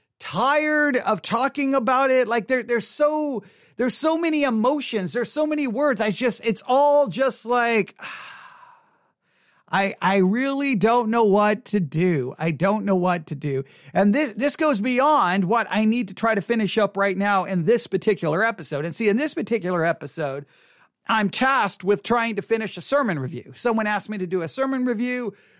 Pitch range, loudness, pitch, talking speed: 195-265 Hz, -22 LUFS, 225 Hz, 185 wpm